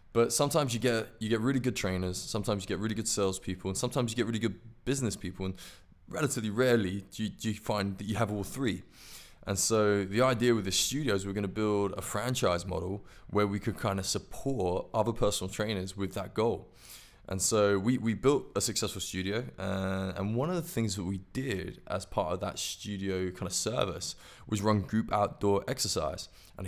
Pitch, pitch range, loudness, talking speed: 105 Hz, 95-115 Hz, -31 LUFS, 200 wpm